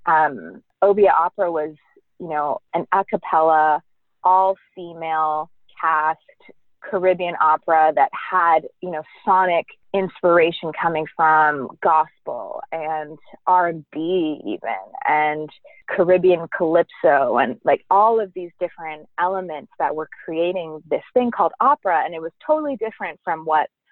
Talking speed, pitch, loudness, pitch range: 130 wpm, 170 Hz, -20 LUFS, 155-190 Hz